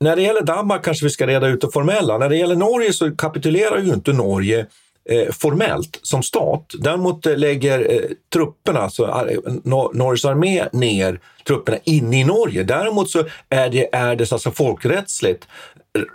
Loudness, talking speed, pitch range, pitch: -18 LUFS, 155 wpm, 130-185 Hz, 155 Hz